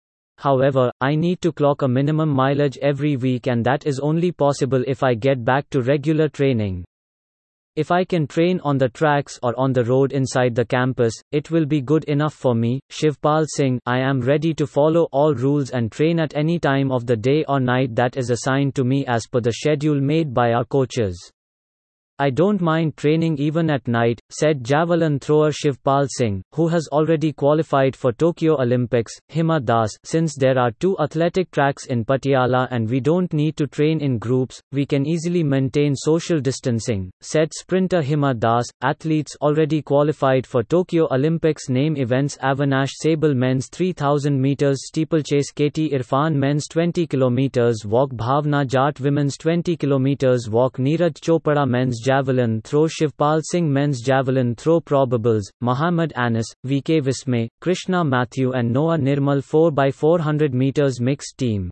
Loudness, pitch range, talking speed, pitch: -20 LUFS, 130-155 Hz, 165 wpm, 140 Hz